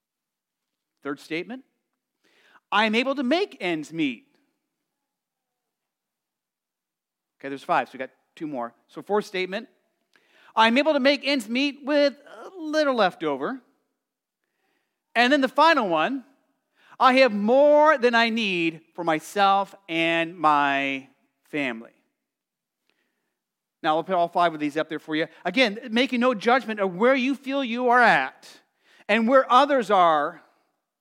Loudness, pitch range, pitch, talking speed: -22 LUFS, 175-285 Hz, 245 Hz, 140 wpm